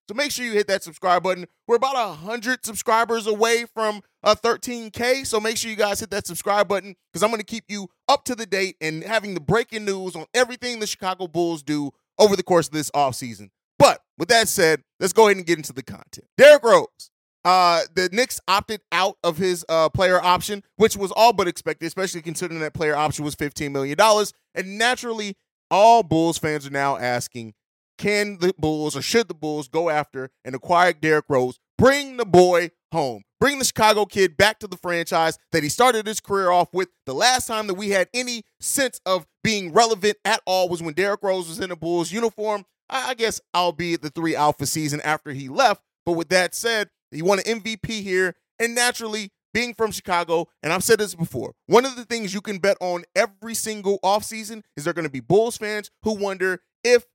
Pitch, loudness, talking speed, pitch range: 190 Hz, -21 LUFS, 215 wpm, 165-220 Hz